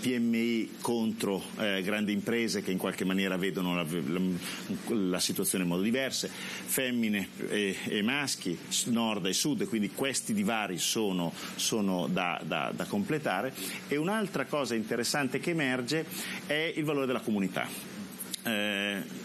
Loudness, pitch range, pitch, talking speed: -31 LUFS, 95-130 Hz, 110 Hz, 145 wpm